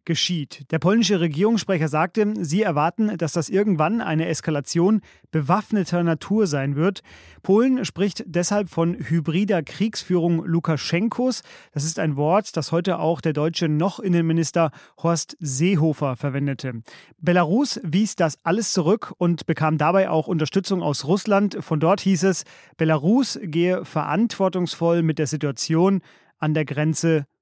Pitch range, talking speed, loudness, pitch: 160-195 Hz, 135 wpm, -22 LUFS, 170 Hz